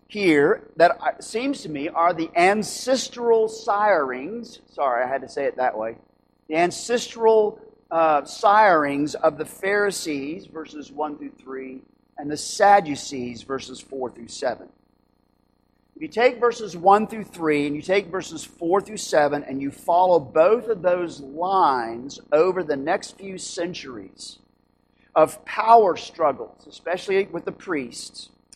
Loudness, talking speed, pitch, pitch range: -22 LUFS, 145 wpm, 175 Hz, 145-215 Hz